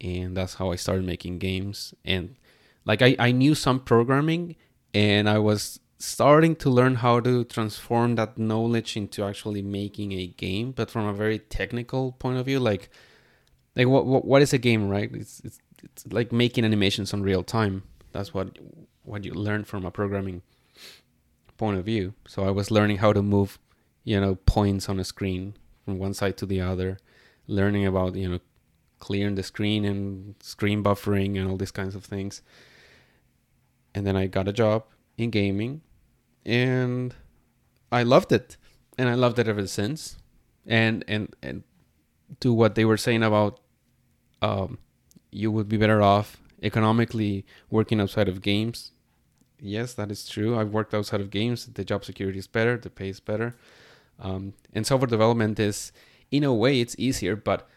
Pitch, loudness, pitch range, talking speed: 105 Hz, -25 LUFS, 100-120 Hz, 175 wpm